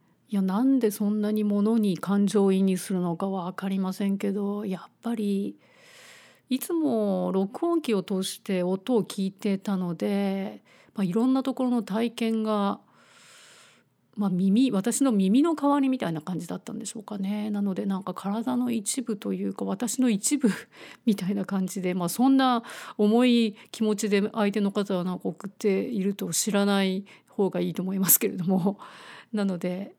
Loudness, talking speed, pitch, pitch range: -26 LUFS, 320 characters per minute, 205 Hz, 190-230 Hz